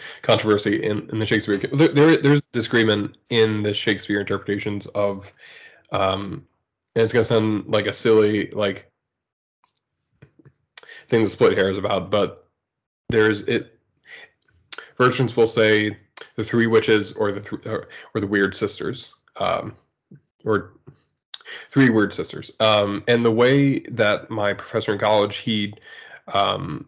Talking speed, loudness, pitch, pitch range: 140 wpm, -20 LUFS, 110 Hz, 100-115 Hz